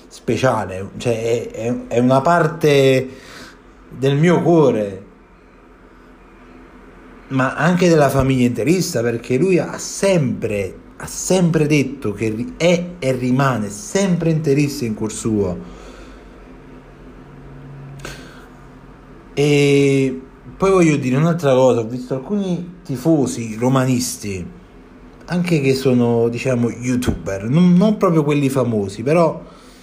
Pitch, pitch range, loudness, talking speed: 130 Hz, 115-155 Hz, -17 LUFS, 105 wpm